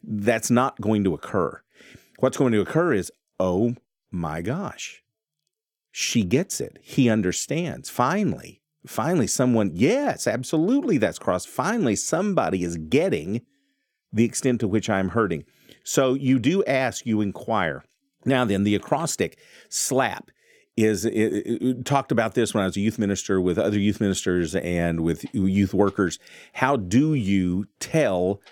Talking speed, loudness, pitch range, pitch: 150 wpm, -23 LUFS, 95-125 Hz, 110 Hz